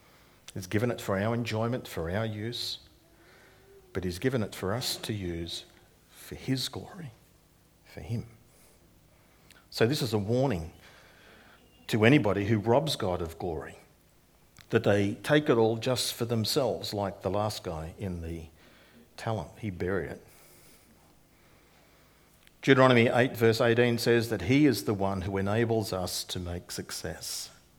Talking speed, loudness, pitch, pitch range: 145 wpm, -29 LUFS, 110 Hz, 95-120 Hz